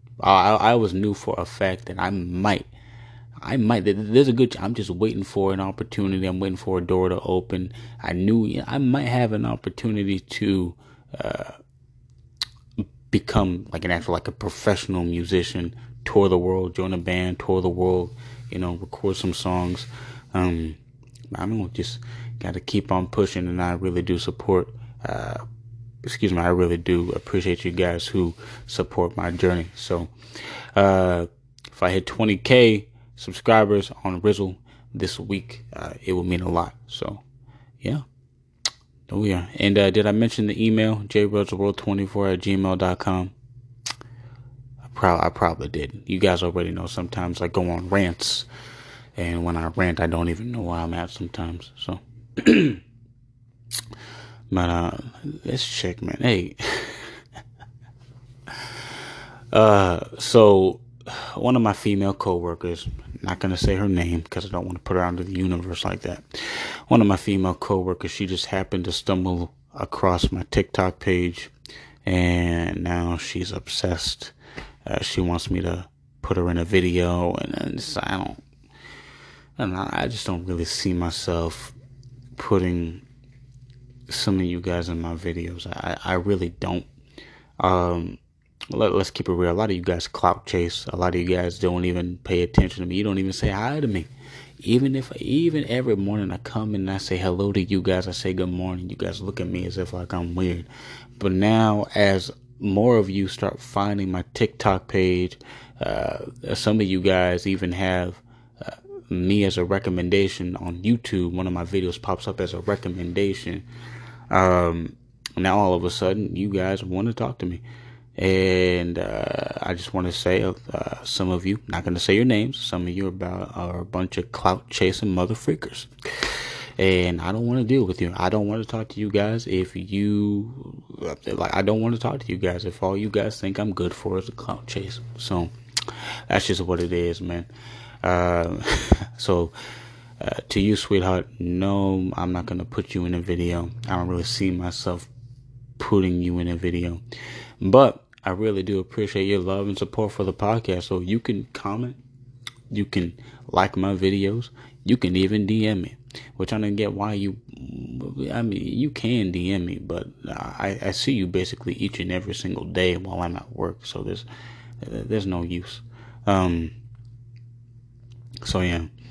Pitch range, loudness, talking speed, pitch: 90-120 Hz, -24 LUFS, 175 wpm, 100 Hz